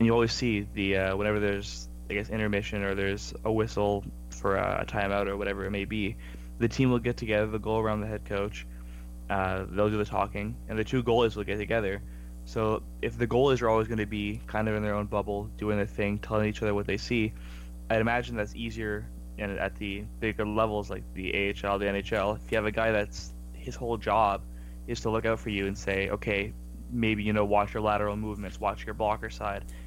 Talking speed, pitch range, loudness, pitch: 225 wpm, 100-110 Hz, -30 LUFS, 105 Hz